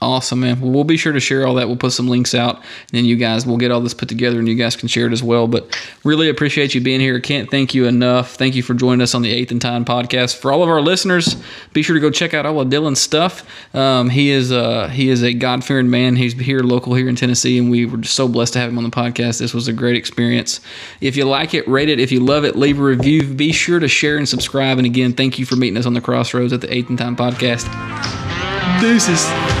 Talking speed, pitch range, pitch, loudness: 280 wpm, 120-135 Hz, 125 Hz, -15 LUFS